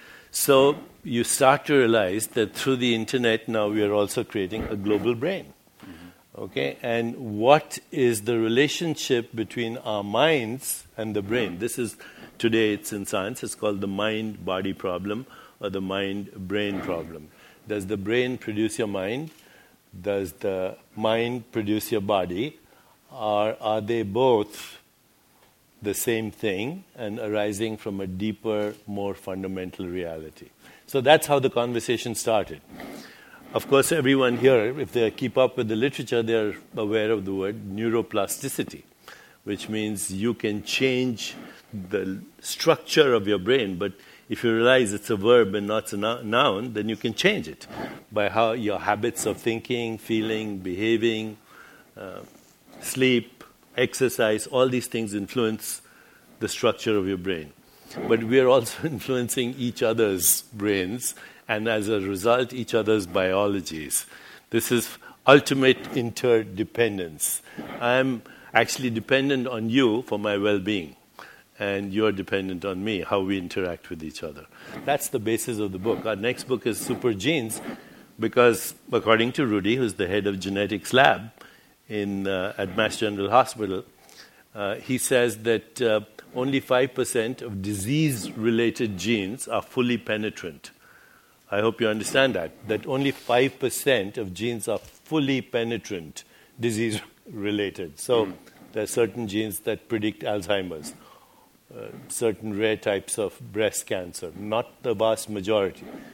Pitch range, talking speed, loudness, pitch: 105-120 Hz, 145 wpm, -25 LUFS, 110 Hz